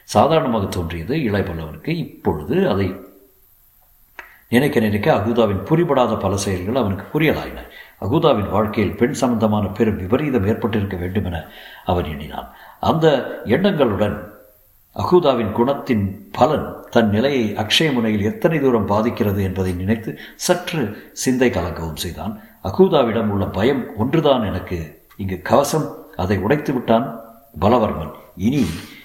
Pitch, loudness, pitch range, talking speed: 105 Hz, -19 LUFS, 95-120 Hz, 110 wpm